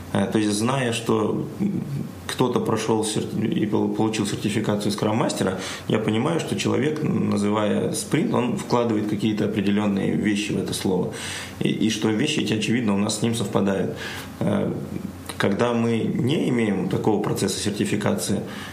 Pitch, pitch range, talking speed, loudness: 105 Hz, 105-110 Hz, 135 wpm, -23 LUFS